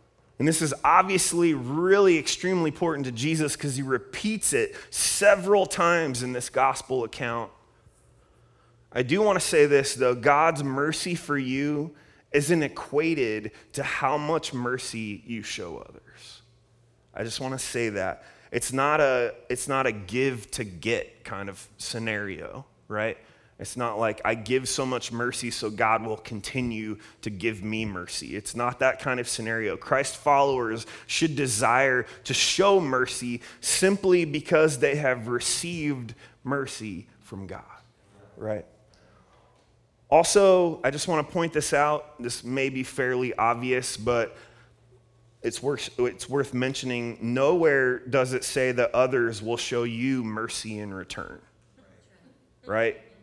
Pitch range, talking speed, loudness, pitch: 115-145 Hz, 145 wpm, -25 LUFS, 125 Hz